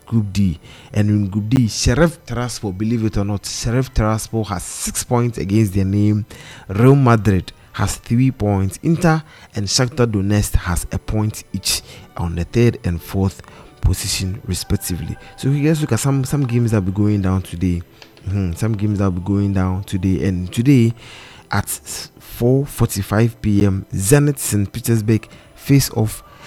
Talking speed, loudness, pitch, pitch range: 165 wpm, -18 LUFS, 105 Hz, 95-120 Hz